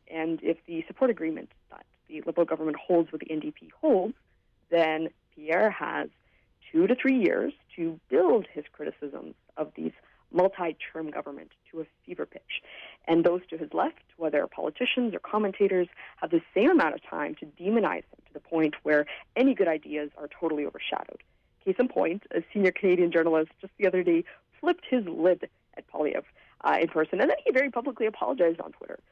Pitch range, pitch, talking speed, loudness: 160-225 Hz, 170 Hz, 180 wpm, -28 LUFS